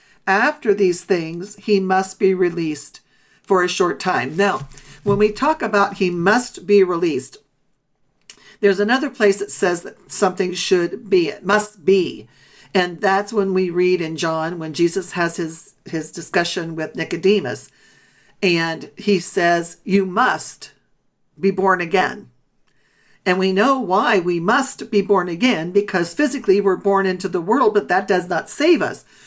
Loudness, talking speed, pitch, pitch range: -19 LUFS, 160 wpm, 190 Hz, 175-205 Hz